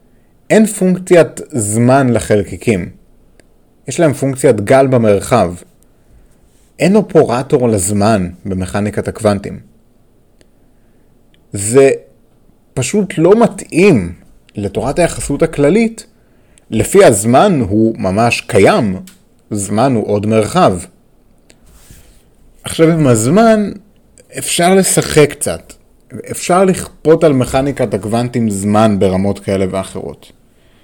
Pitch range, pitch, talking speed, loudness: 105-165 Hz, 125 Hz, 90 wpm, -12 LUFS